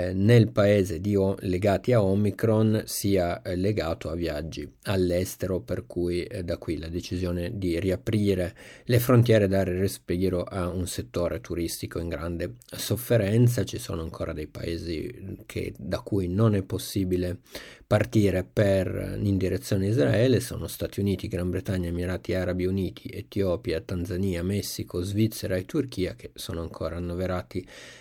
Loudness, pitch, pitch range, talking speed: -27 LUFS, 95 Hz, 90-105 Hz, 140 wpm